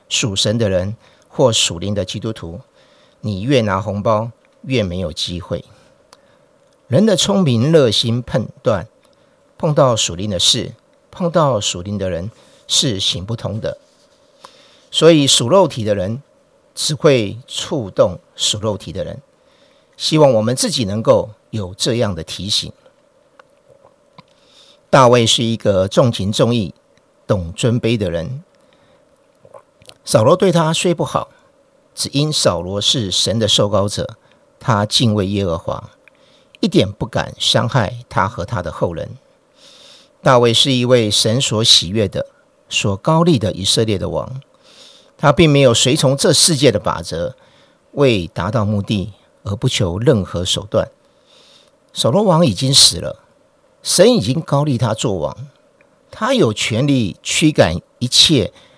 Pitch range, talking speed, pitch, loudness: 105-140 Hz, 195 characters per minute, 115 Hz, -15 LUFS